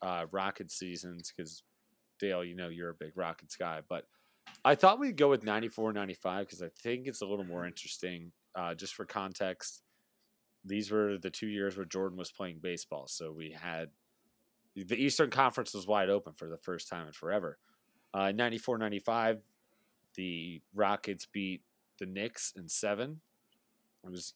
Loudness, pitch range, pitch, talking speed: -35 LUFS, 90-110 Hz, 100 Hz, 165 wpm